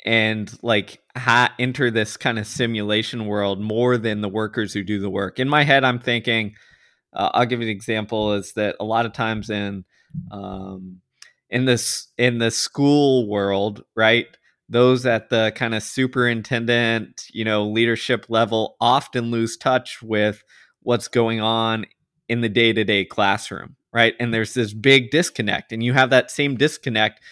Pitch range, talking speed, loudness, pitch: 105-125 Hz, 165 wpm, -20 LUFS, 115 Hz